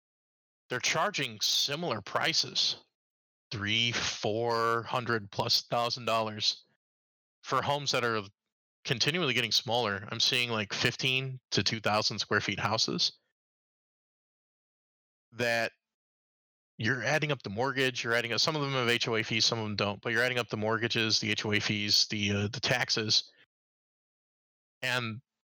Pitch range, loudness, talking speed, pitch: 105-125 Hz, -29 LUFS, 140 wpm, 115 Hz